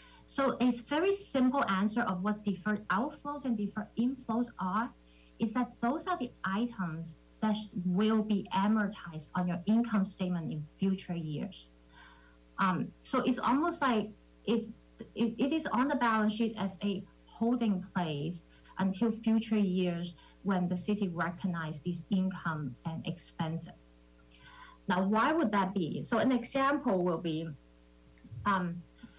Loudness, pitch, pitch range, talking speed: -33 LUFS, 200 Hz, 175-230 Hz, 140 wpm